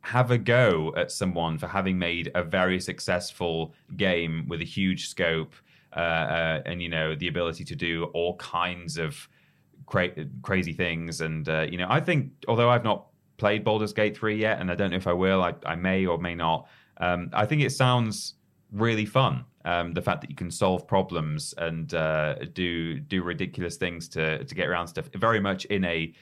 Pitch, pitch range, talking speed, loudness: 90 Hz, 85-105 Hz, 200 wpm, -27 LUFS